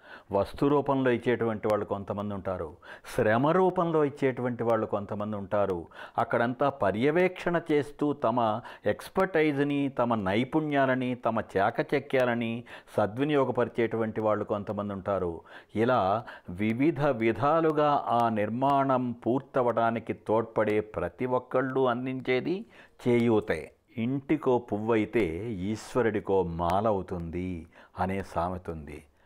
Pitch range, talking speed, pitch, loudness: 105-135 Hz, 90 wpm, 115 Hz, -28 LUFS